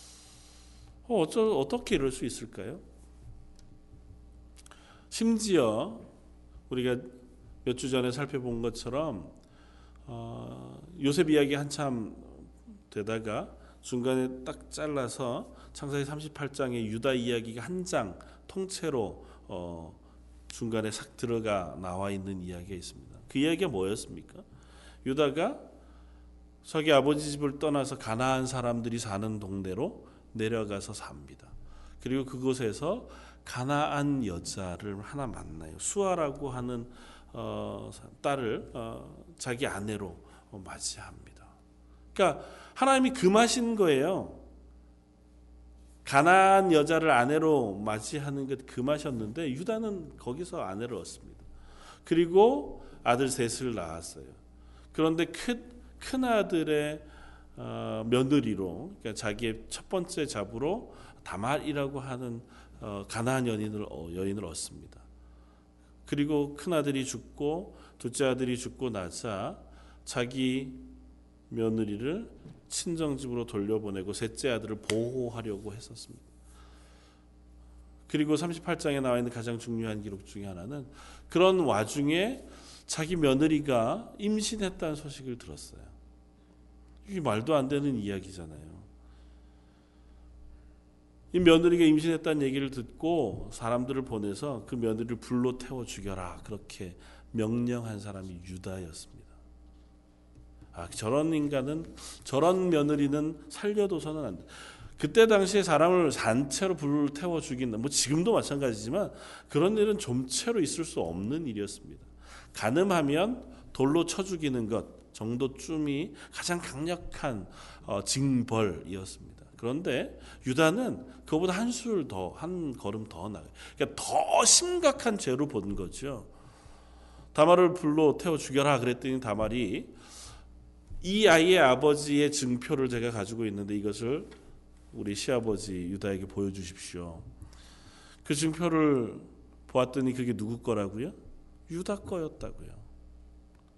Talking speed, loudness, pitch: 260 characters per minute, -30 LUFS, 115 Hz